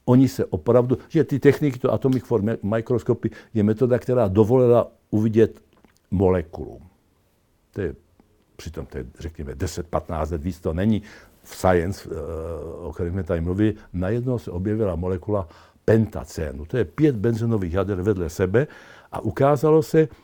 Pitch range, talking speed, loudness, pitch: 90-120 Hz, 150 wpm, -22 LUFS, 110 Hz